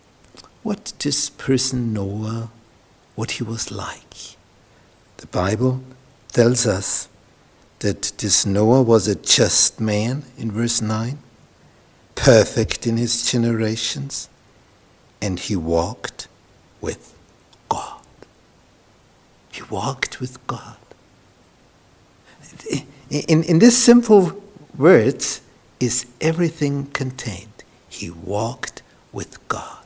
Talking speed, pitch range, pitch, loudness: 95 wpm, 105-135 Hz, 120 Hz, -19 LUFS